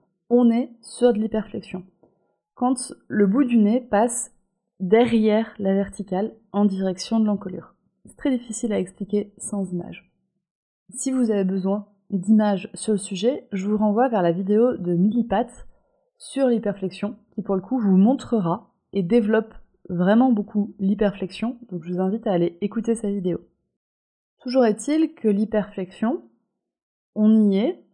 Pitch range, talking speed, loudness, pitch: 190-230 Hz, 150 wpm, -22 LUFS, 210 Hz